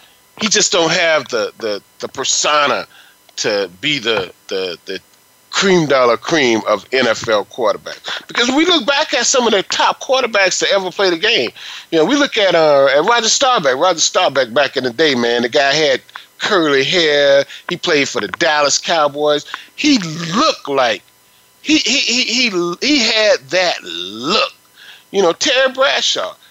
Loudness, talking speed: -14 LUFS, 170 wpm